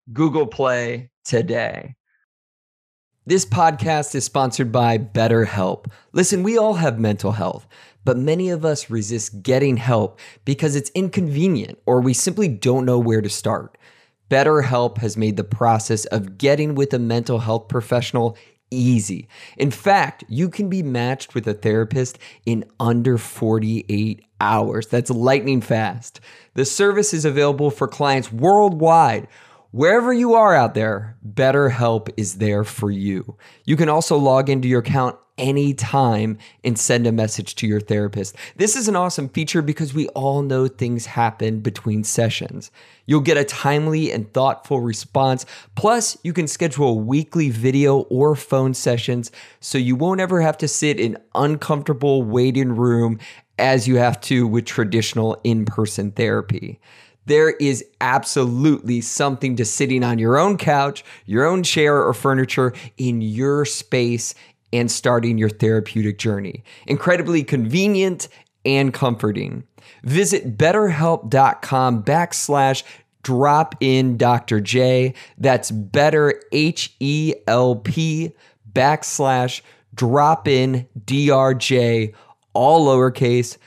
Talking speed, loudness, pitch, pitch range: 135 wpm, -19 LUFS, 130 Hz, 115-145 Hz